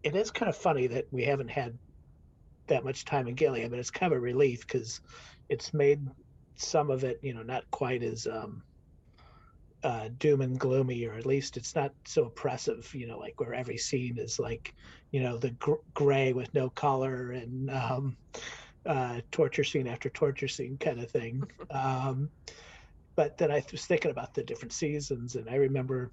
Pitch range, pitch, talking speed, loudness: 120-140 Hz, 130 Hz, 195 wpm, -32 LUFS